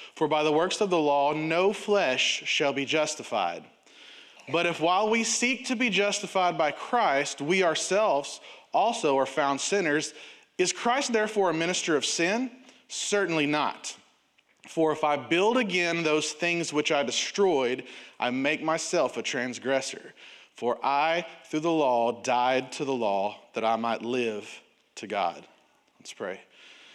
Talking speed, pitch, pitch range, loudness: 155 wpm, 160 Hz, 140-200 Hz, -26 LUFS